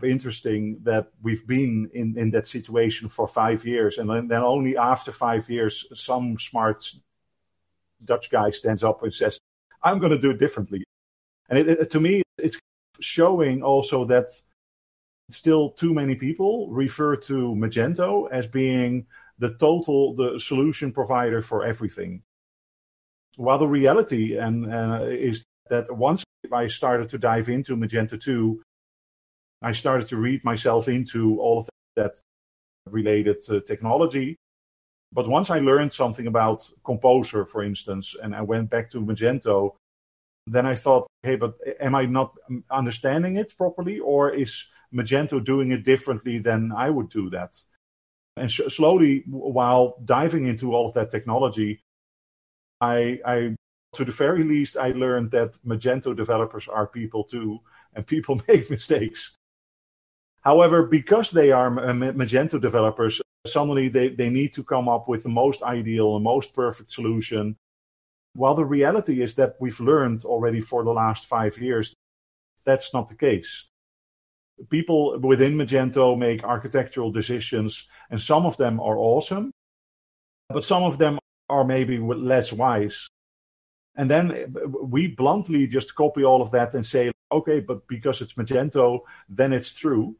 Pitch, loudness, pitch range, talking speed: 125 Hz, -23 LUFS, 110-135 Hz, 150 wpm